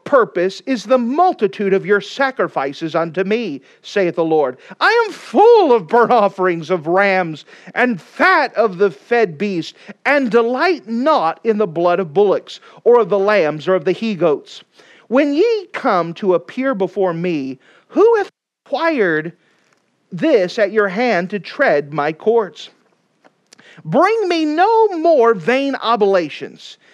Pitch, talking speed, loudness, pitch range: 220 Hz, 150 wpm, -16 LUFS, 180-285 Hz